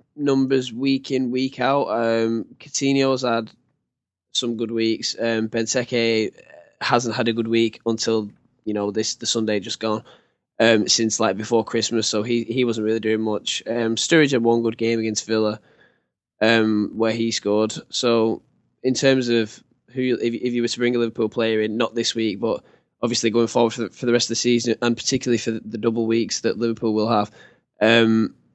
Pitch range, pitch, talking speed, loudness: 110-120 Hz, 115 Hz, 190 wpm, -21 LUFS